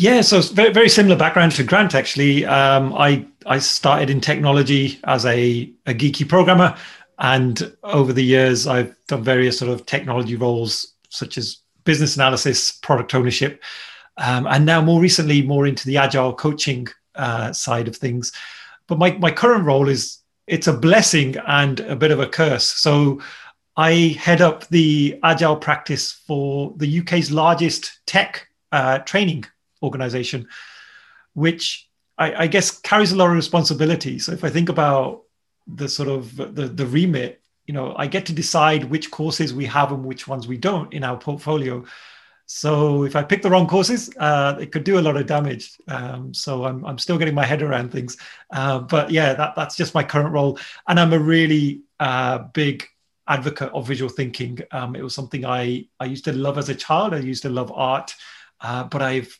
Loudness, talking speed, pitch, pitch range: -18 LUFS, 185 wpm, 145 Hz, 130-160 Hz